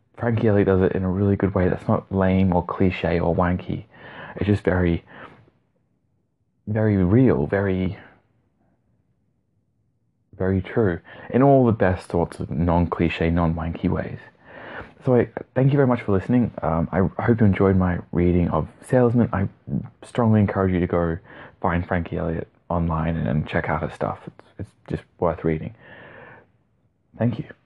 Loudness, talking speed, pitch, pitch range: -22 LUFS, 155 wpm, 95 Hz, 85-110 Hz